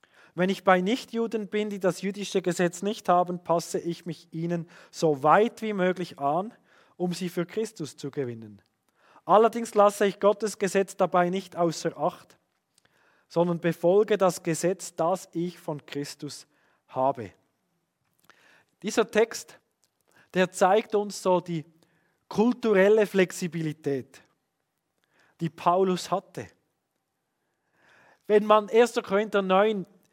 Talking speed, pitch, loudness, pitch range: 120 wpm, 180 Hz, -26 LUFS, 165-205 Hz